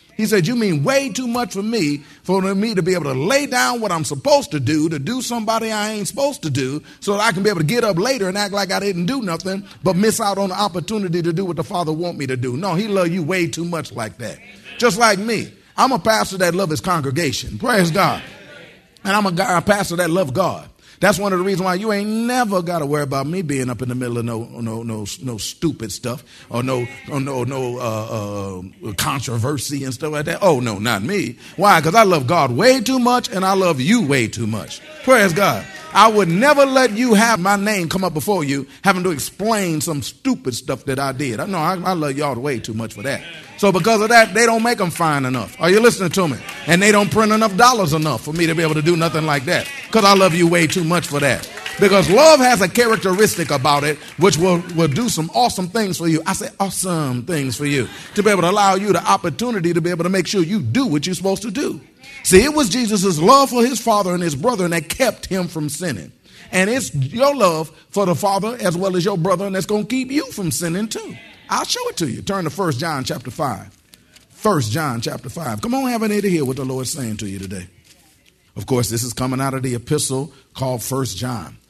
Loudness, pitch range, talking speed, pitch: -18 LUFS, 145-210 Hz, 255 wpm, 180 Hz